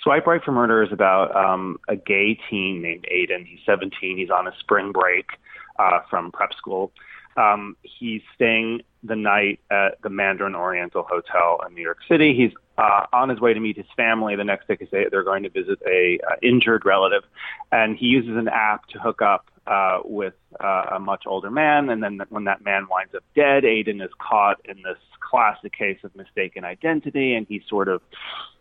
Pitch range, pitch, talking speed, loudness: 100-145 Hz, 110 Hz, 195 wpm, -21 LUFS